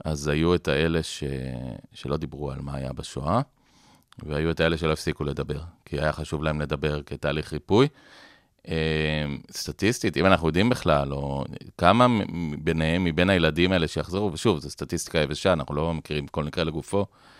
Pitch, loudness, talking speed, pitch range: 80 Hz, -25 LUFS, 155 wpm, 75-85 Hz